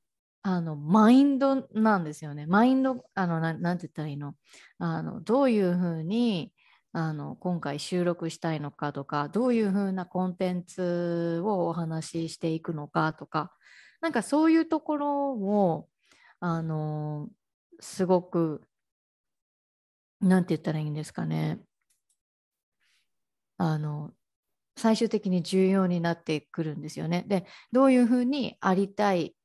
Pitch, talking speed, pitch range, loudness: 175 Hz, 245 characters per minute, 160-215 Hz, -27 LUFS